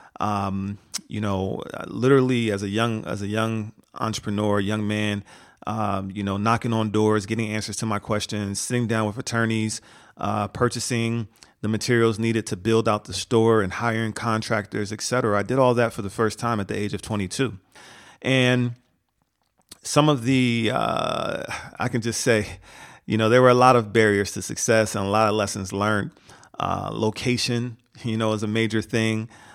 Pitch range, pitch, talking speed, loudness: 105-115 Hz, 110 Hz, 180 wpm, -23 LUFS